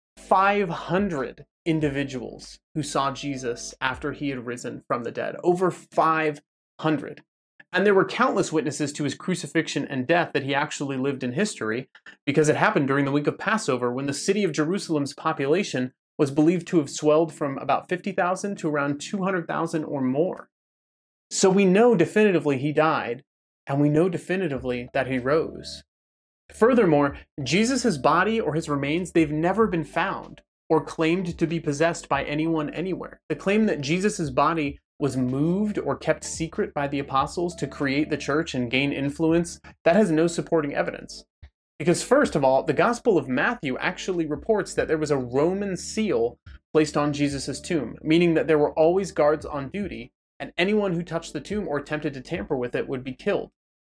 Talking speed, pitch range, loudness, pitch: 175 wpm, 140-180 Hz, -24 LUFS, 155 Hz